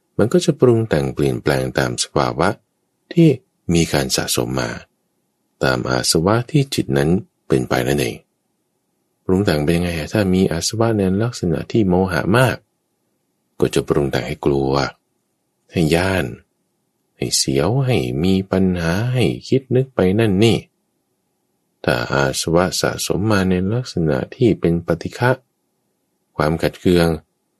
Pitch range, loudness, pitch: 75-110 Hz, -18 LUFS, 90 Hz